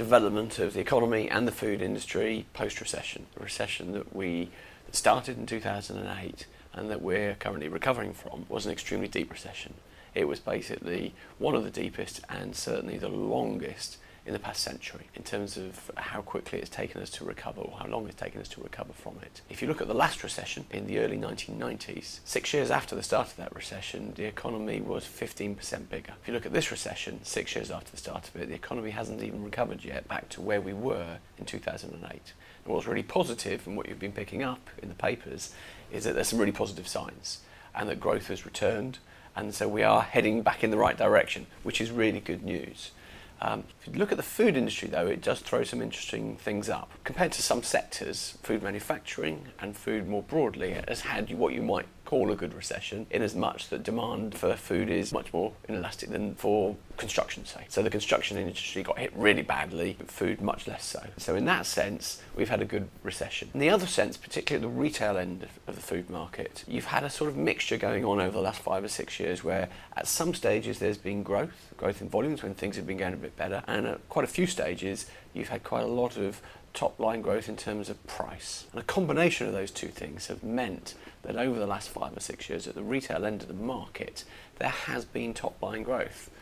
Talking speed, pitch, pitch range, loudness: 220 wpm, 105 Hz, 95-115 Hz, -32 LUFS